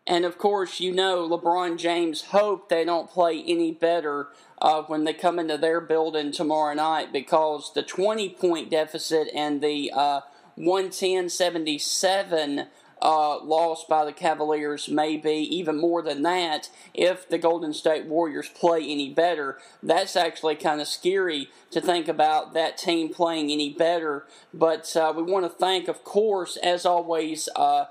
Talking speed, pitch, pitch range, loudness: 155 wpm, 165 Hz, 155-175 Hz, -25 LUFS